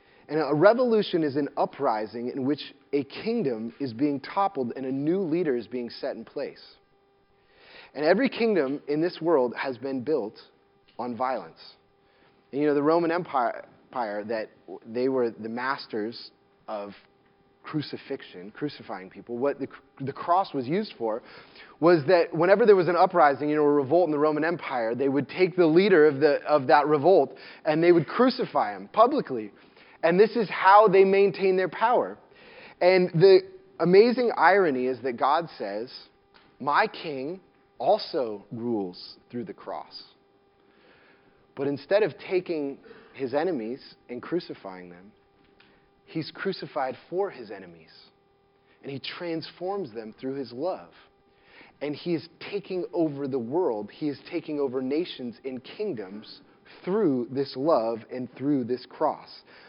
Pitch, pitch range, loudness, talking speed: 150 Hz, 130-185 Hz, -25 LUFS, 150 wpm